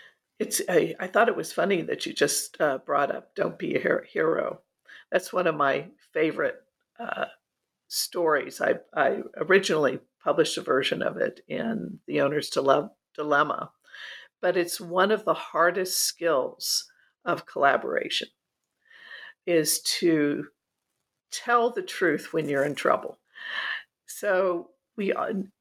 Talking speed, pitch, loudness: 135 wpm, 235 Hz, -26 LUFS